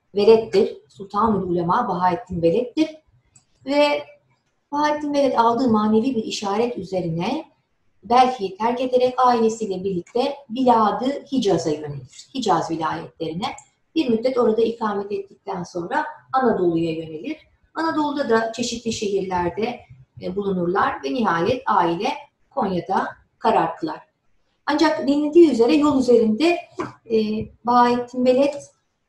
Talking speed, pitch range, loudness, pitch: 100 wpm, 195-275 Hz, -21 LUFS, 230 Hz